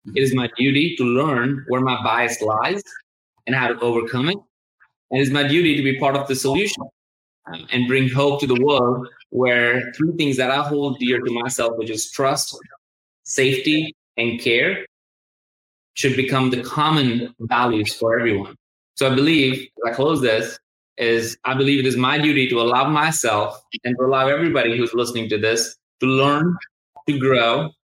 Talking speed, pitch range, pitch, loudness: 175 wpm, 120-140 Hz, 130 Hz, -19 LUFS